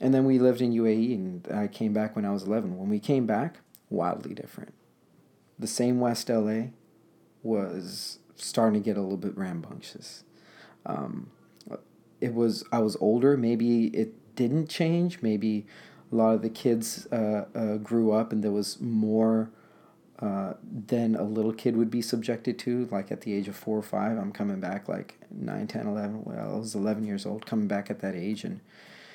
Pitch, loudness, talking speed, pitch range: 110 Hz, -28 LUFS, 190 wpm, 105-120 Hz